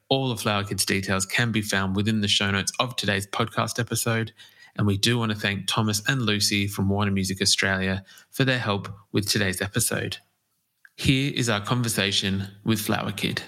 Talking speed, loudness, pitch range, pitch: 185 wpm, -24 LUFS, 100-115 Hz, 105 Hz